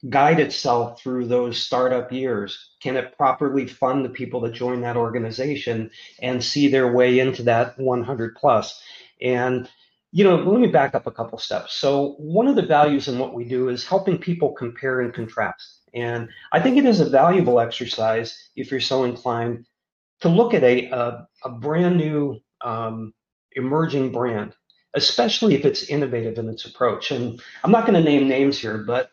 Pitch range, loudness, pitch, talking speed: 120-145 Hz, -21 LUFS, 125 Hz, 185 wpm